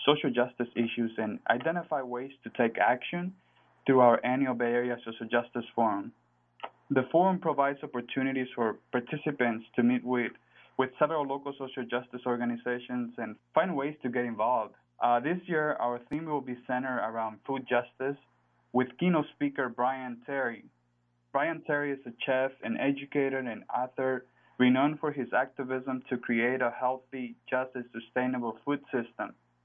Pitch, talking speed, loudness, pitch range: 125 Hz, 155 wpm, -31 LUFS, 120-135 Hz